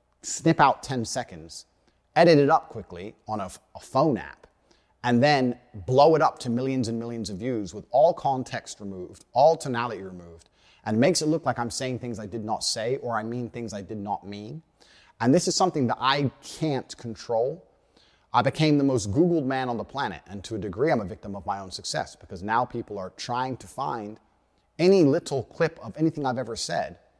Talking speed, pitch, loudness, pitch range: 205 wpm, 120 Hz, -25 LUFS, 110-140 Hz